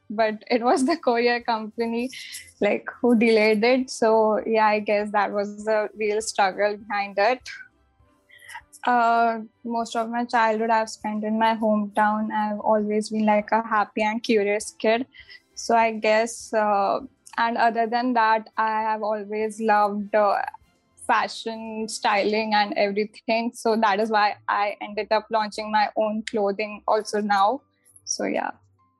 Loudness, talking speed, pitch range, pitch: -23 LUFS, 150 wpm, 210-230 Hz, 220 Hz